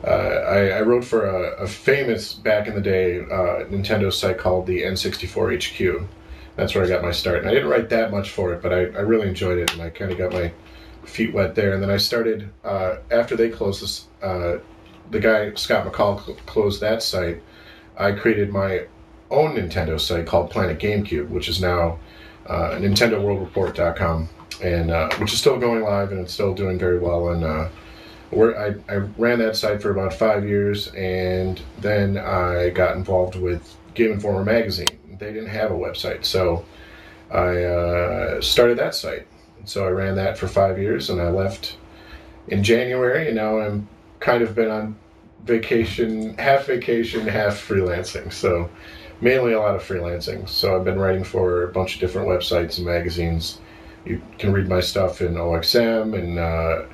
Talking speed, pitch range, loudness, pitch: 185 wpm, 90-110 Hz, -21 LUFS, 95 Hz